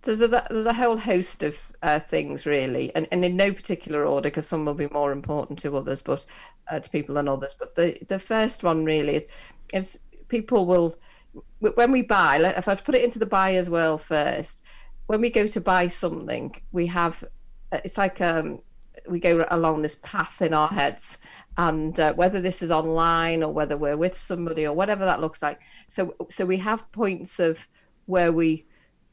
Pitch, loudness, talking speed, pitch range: 175 Hz, -24 LUFS, 200 wpm, 155-195 Hz